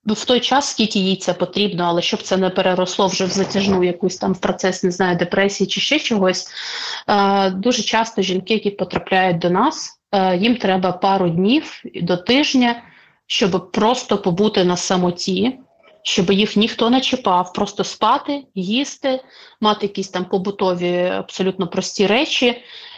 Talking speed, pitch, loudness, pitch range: 155 wpm, 195 Hz, -18 LUFS, 185-230 Hz